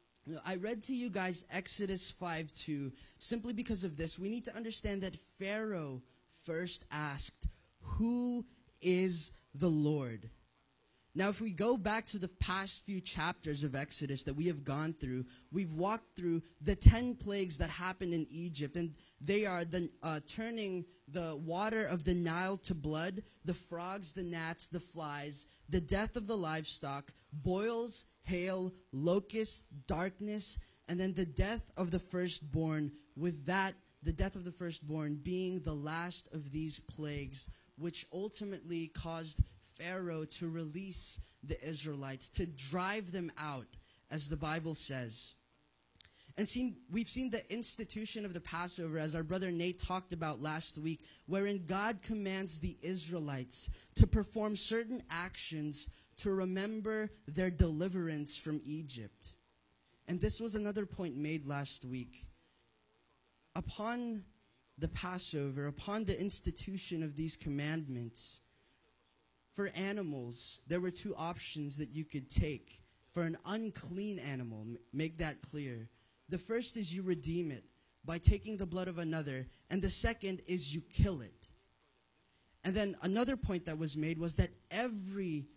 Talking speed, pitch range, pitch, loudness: 150 wpm, 150-195 Hz, 170 Hz, -39 LUFS